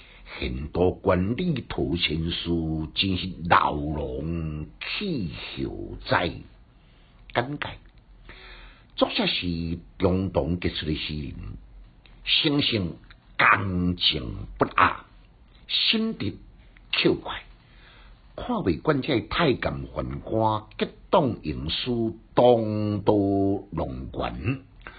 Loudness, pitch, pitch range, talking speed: -25 LUFS, 90 Hz, 80-105 Hz, 125 characters per minute